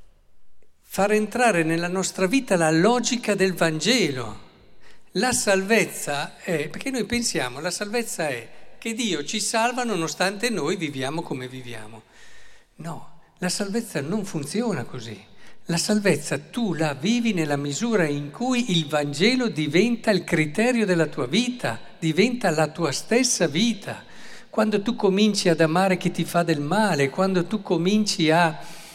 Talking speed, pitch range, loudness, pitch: 145 wpm, 160-220 Hz, -23 LUFS, 185 Hz